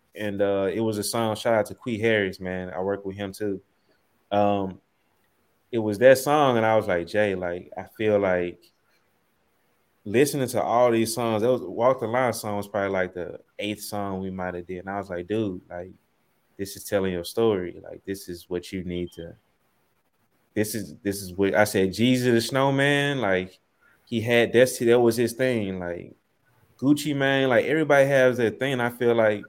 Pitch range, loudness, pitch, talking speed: 95-120 Hz, -24 LUFS, 105 Hz, 200 wpm